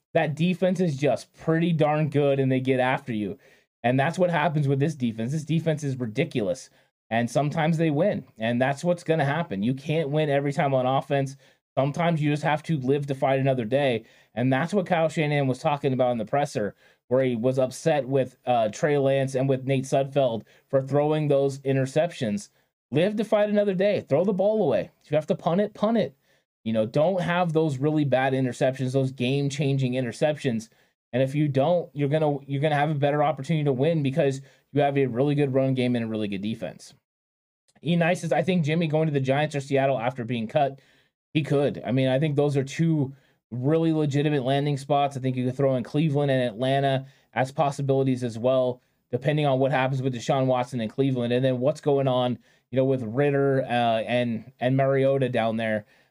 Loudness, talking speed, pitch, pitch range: -25 LUFS, 210 wpm, 135 Hz, 130-150 Hz